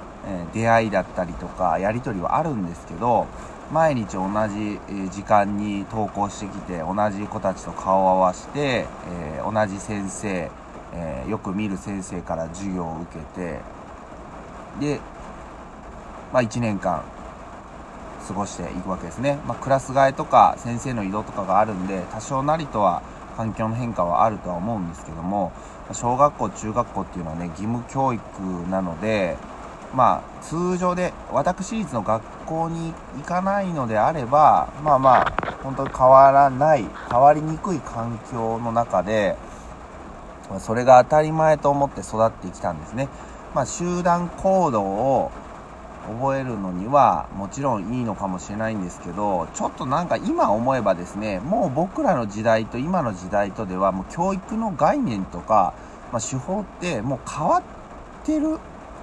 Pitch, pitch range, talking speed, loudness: 110 Hz, 95-140 Hz, 300 characters per minute, -22 LUFS